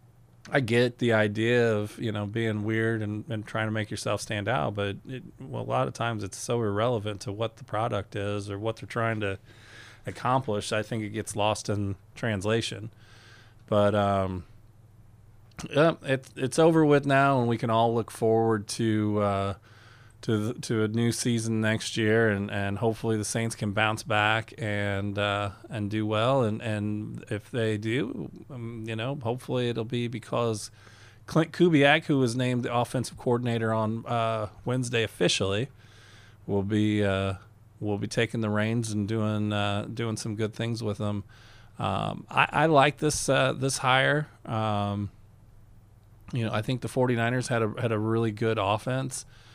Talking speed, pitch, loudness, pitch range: 175 wpm, 110 Hz, -27 LUFS, 105-120 Hz